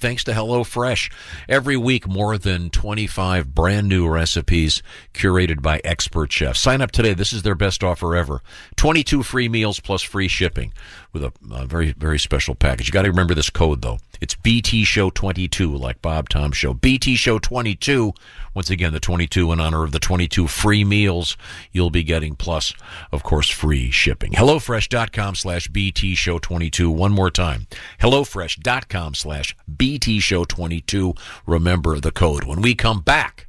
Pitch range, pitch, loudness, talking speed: 80-105 Hz, 90 Hz, -19 LUFS, 165 wpm